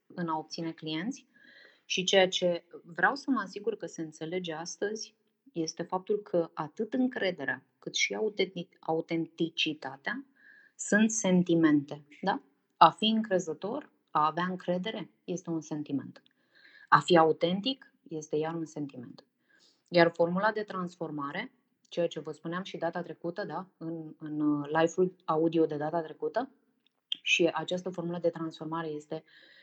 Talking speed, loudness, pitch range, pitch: 135 wpm, -31 LUFS, 160-205 Hz, 170 Hz